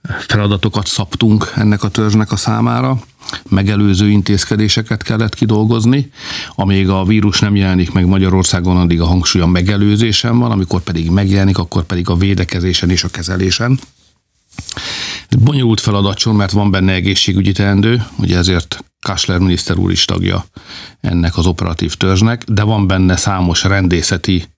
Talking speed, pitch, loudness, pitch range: 140 wpm, 100 Hz, -13 LUFS, 90-110 Hz